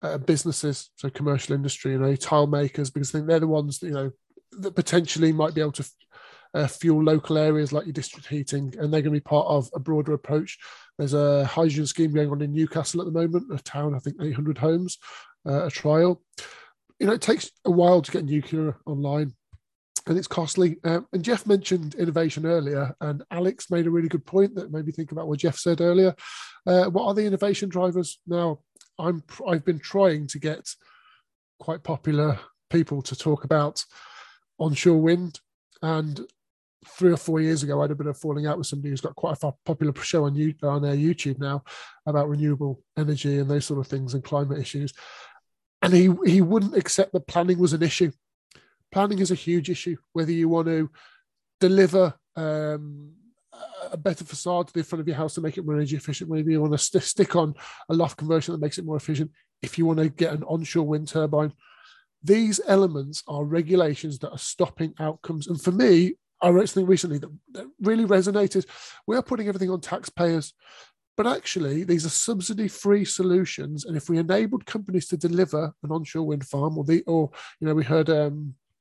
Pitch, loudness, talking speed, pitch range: 160 Hz, -24 LUFS, 205 wpm, 150-180 Hz